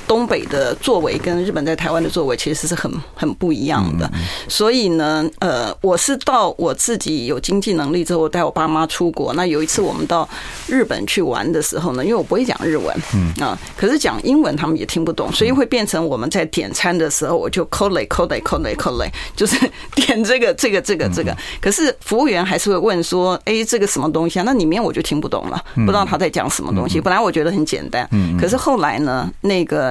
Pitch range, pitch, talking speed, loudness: 160-220 Hz, 175 Hz, 365 characters per minute, -17 LUFS